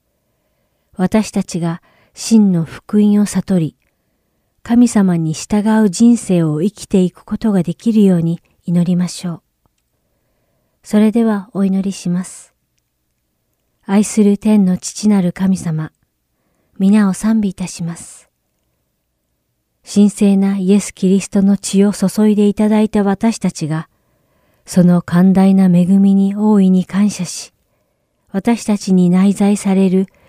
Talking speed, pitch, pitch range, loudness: 230 characters per minute, 195 Hz, 175-205 Hz, -14 LUFS